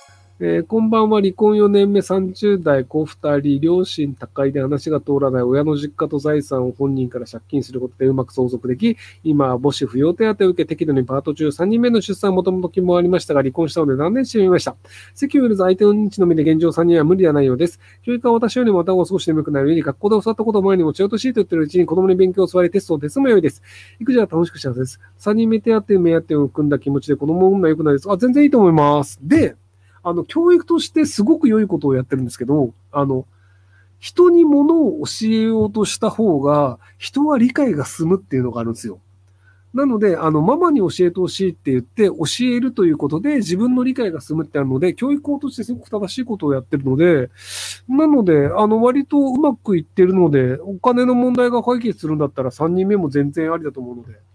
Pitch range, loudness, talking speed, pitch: 140-215 Hz, -17 LUFS, 445 characters per minute, 170 Hz